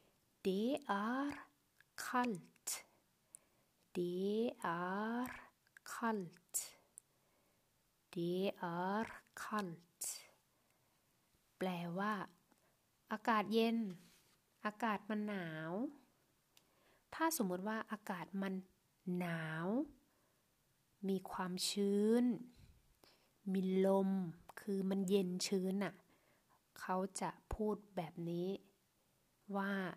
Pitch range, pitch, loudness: 185-215 Hz, 195 Hz, -41 LUFS